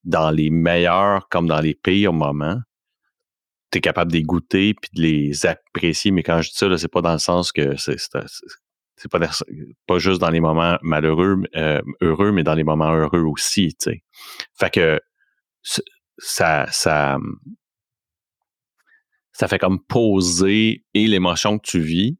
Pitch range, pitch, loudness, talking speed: 80-100 Hz, 85 Hz, -19 LUFS, 170 wpm